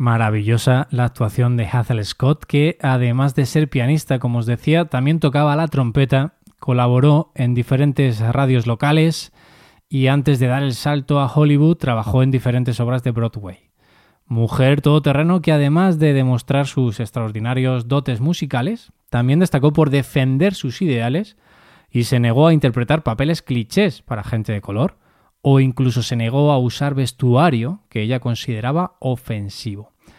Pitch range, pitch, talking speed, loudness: 120-150 Hz, 130 Hz, 150 wpm, -18 LUFS